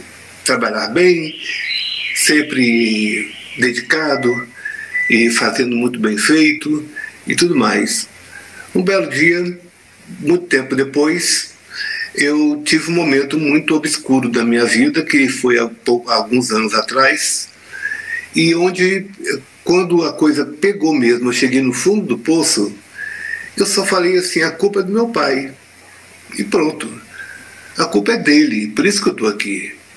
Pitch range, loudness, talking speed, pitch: 125-200 Hz, -15 LUFS, 135 wpm, 155 Hz